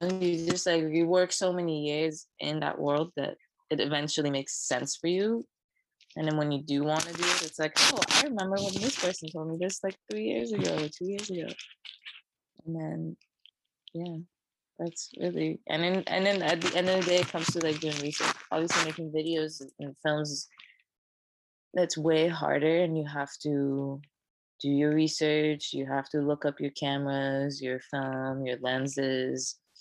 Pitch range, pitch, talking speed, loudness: 140-170 Hz, 155 Hz, 185 wpm, -29 LUFS